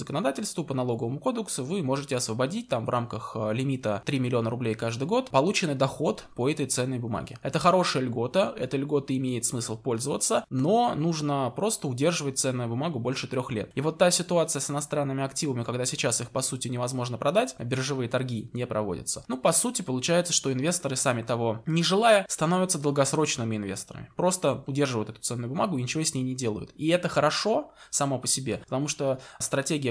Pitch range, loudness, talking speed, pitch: 120-155 Hz, -27 LUFS, 180 wpm, 135 Hz